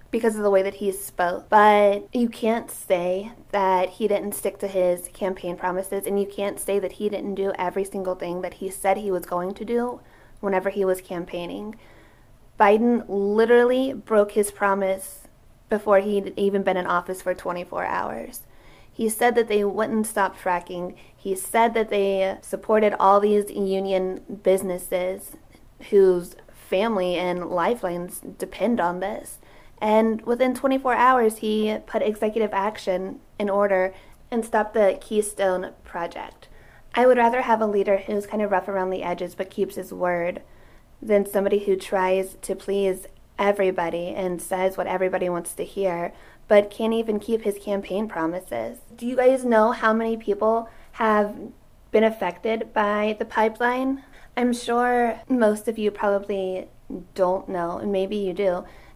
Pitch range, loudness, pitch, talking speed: 185-220 Hz, -23 LUFS, 200 Hz, 160 wpm